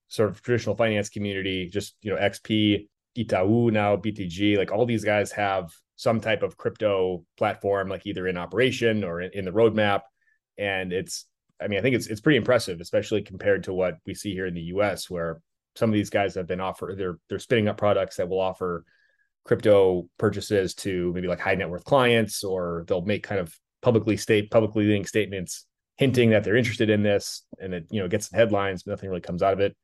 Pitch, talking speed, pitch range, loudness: 100 Hz, 215 wpm, 95-110 Hz, -25 LUFS